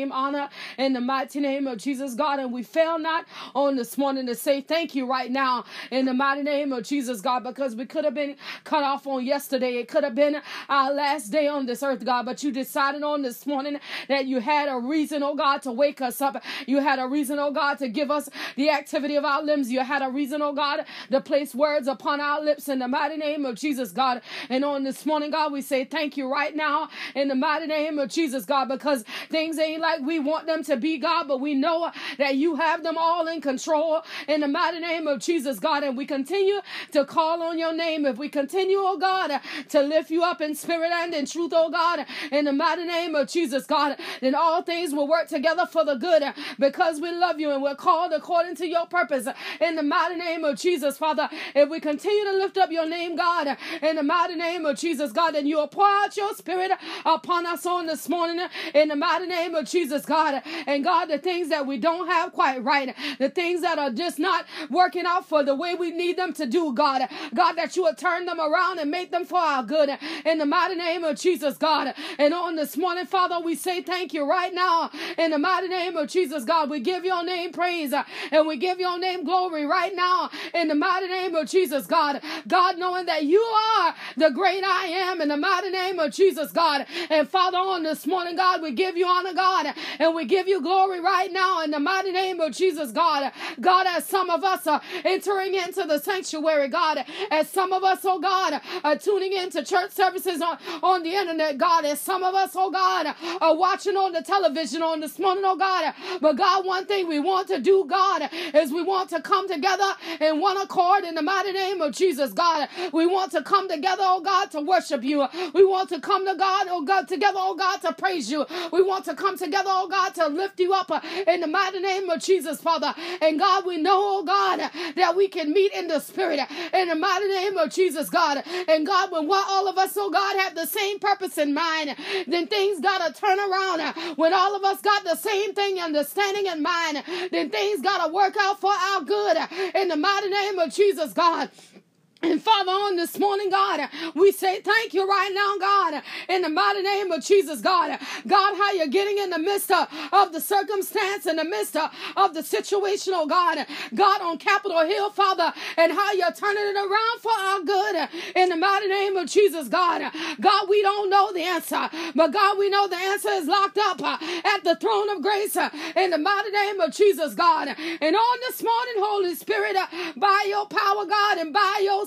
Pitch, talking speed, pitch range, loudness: 335 Hz, 220 wpm, 300-375 Hz, -23 LUFS